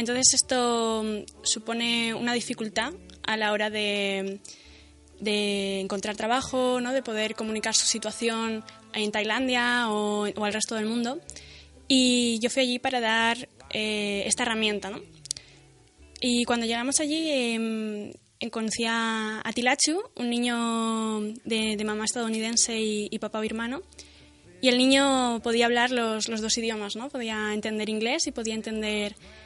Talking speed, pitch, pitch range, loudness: 145 wpm, 225 Hz, 215-240 Hz, -26 LUFS